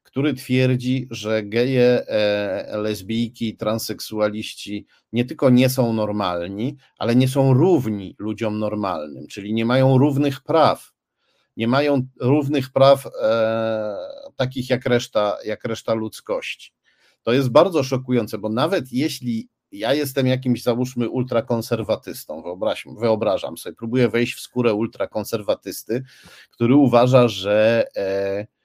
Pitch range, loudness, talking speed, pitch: 110-130 Hz, -20 LUFS, 120 wpm, 120 Hz